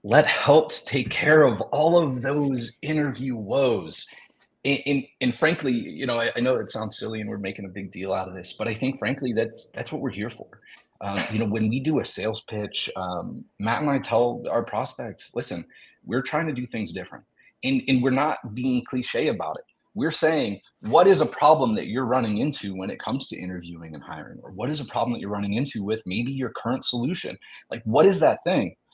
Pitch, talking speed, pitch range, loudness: 125 Hz, 225 wpm, 105-135 Hz, -24 LUFS